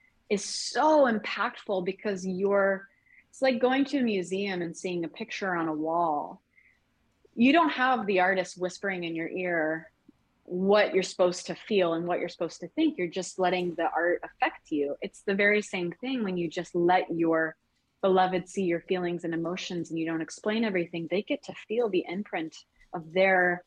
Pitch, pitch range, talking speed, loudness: 185 Hz, 170-205 Hz, 190 wpm, -28 LUFS